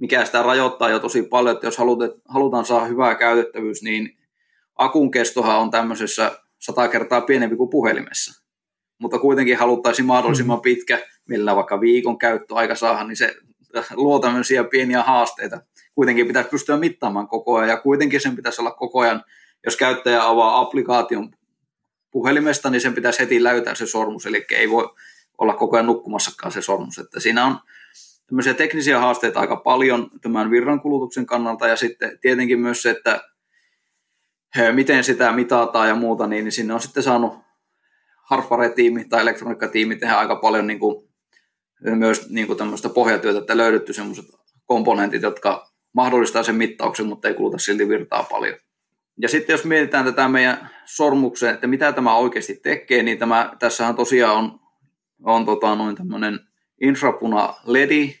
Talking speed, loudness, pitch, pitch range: 155 wpm, -19 LUFS, 120 Hz, 115-130 Hz